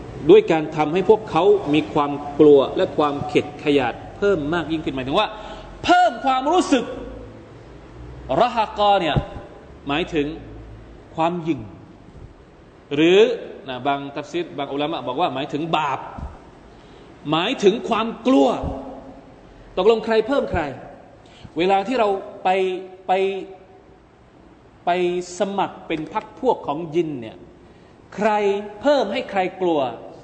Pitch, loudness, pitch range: 185 Hz, -20 LUFS, 150-220 Hz